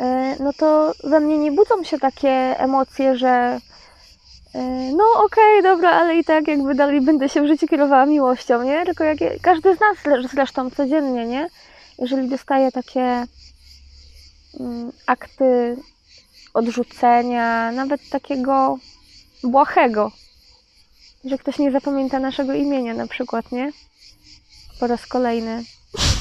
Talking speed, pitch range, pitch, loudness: 125 wpm, 250-300 Hz, 270 Hz, -18 LUFS